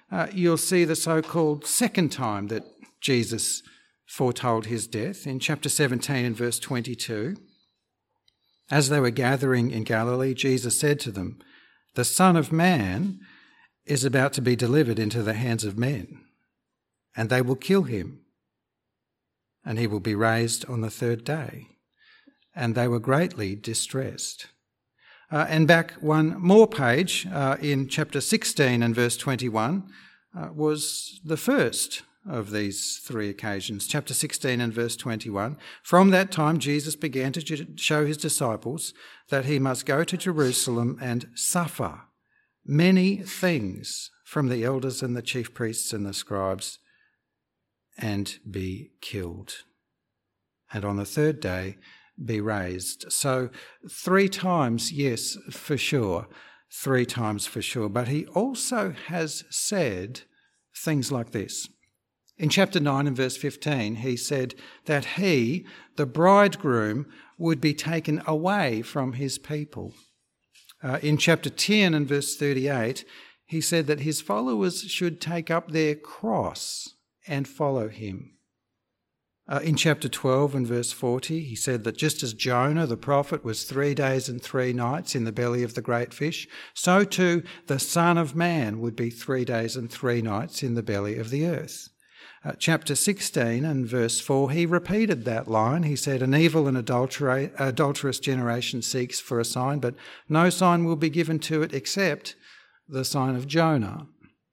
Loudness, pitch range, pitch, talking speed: -25 LUFS, 120-160 Hz, 140 Hz, 150 wpm